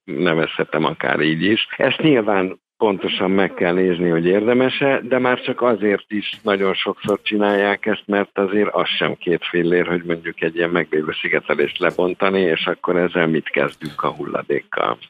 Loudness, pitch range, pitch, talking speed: -19 LUFS, 90-105 Hz, 95 Hz, 160 wpm